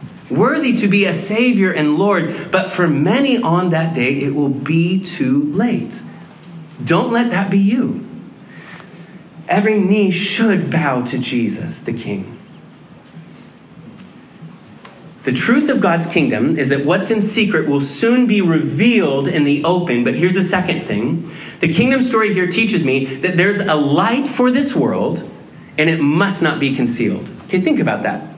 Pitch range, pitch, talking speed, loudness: 155-215 Hz, 180 Hz, 160 wpm, -16 LUFS